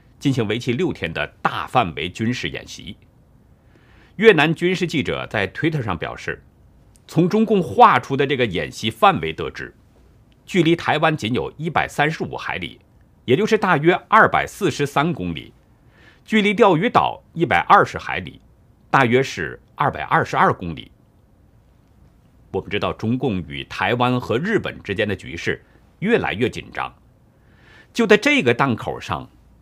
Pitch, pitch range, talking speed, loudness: 140 Hz, 115-180 Hz, 245 characters per minute, -19 LUFS